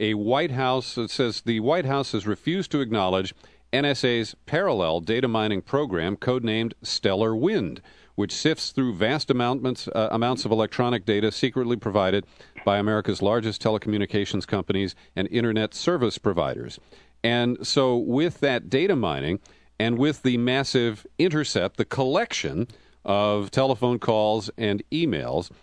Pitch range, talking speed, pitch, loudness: 105-130 Hz, 135 wpm, 115 Hz, -24 LUFS